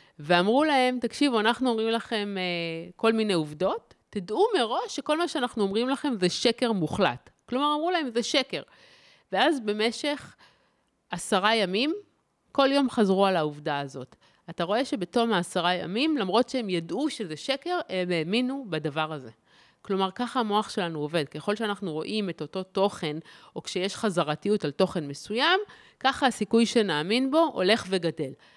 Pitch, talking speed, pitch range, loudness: 210 Hz, 150 wpm, 175-255 Hz, -27 LUFS